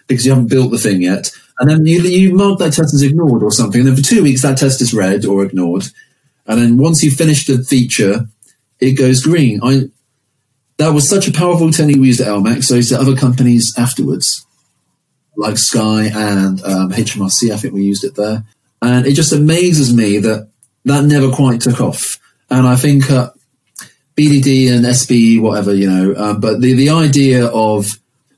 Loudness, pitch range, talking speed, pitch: -11 LUFS, 110-140 Hz, 200 wpm, 125 Hz